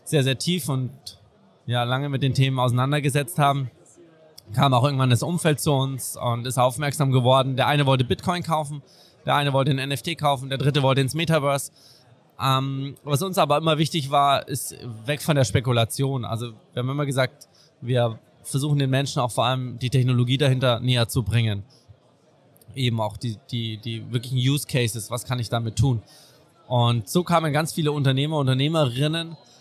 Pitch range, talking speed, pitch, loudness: 125-145 Hz, 180 wpm, 135 Hz, -23 LUFS